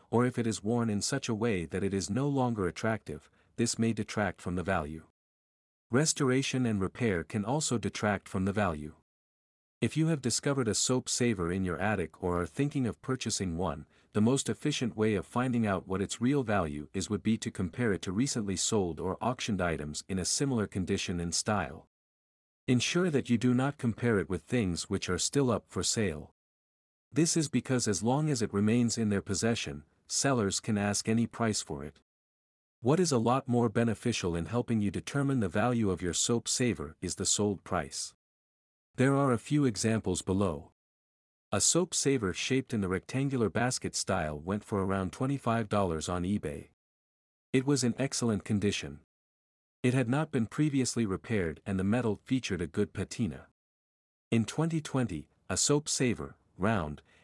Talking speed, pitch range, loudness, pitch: 180 wpm, 90-125 Hz, -31 LUFS, 105 Hz